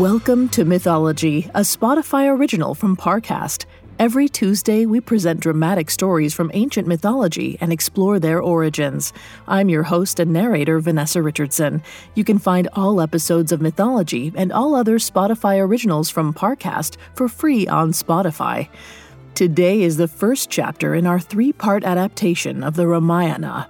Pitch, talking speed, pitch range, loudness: 180 Hz, 150 wpm, 165-210 Hz, -18 LUFS